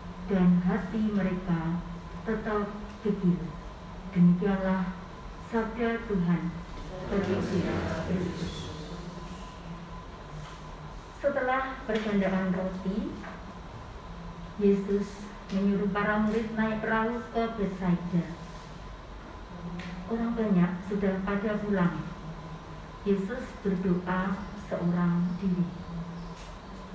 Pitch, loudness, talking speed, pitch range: 195 Hz, -30 LUFS, 65 wpm, 175-210 Hz